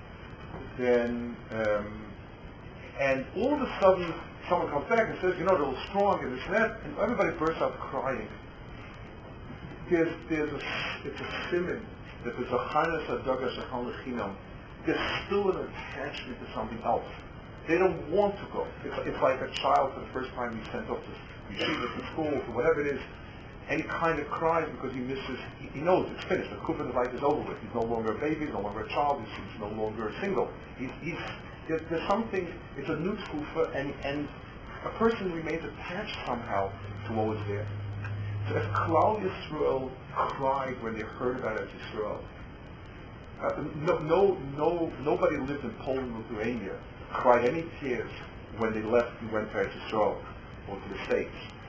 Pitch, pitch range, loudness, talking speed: 130 Hz, 110-160 Hz, -31 LUFS, 175 wpm